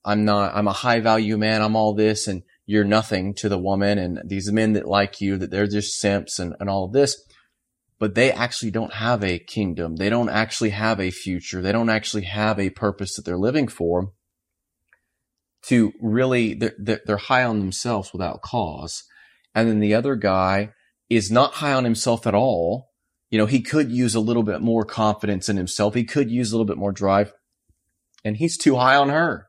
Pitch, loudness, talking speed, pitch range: 105 Hz, -21 LUFS, 205 wpm, 100-115 Hz